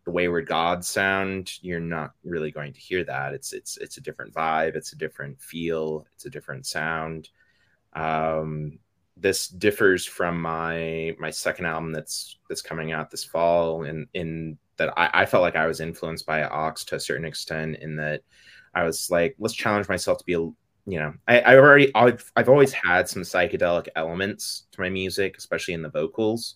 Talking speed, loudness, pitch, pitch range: 190 wpm, -23 LUFS, 80 Hz, 80-95 Hz